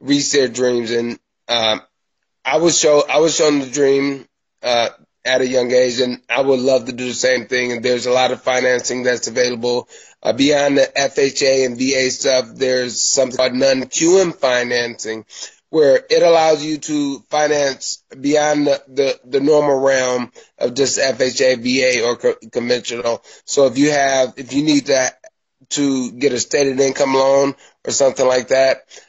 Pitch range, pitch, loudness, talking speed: 125-145 Hz, 135 Hz, -16 LUFS, 170 wpm